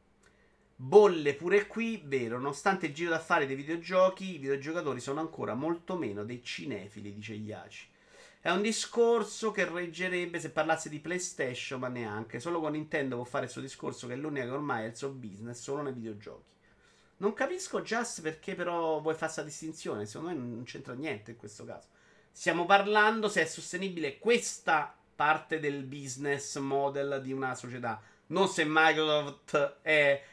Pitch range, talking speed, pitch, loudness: 135-180 Hz, 170 wpm, 155 Hz, -31 LUFS